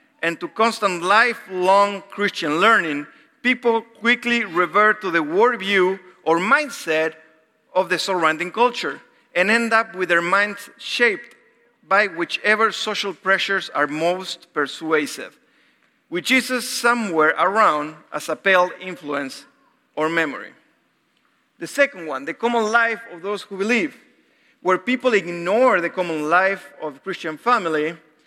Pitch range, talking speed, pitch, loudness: 165-230 Hz, 130 wpm, 190 Hz, -20 LUFS